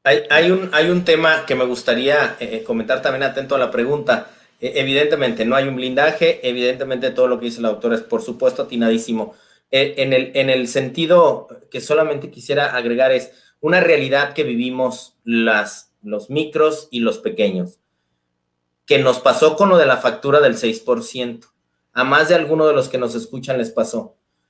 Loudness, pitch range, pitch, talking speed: -17 LUFS, 115-150 Hz, 130 Hz, 185 wpm